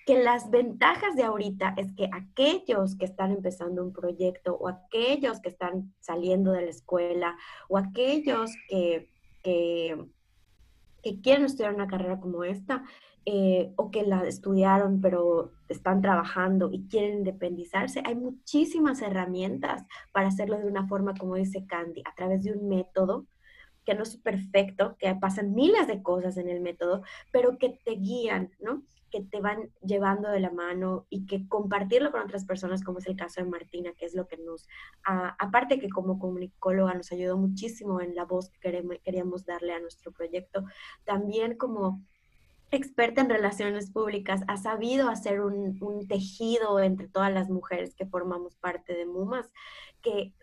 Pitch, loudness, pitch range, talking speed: 195 Hz, -29 LUFS, 180-215 Hz, 165 wpm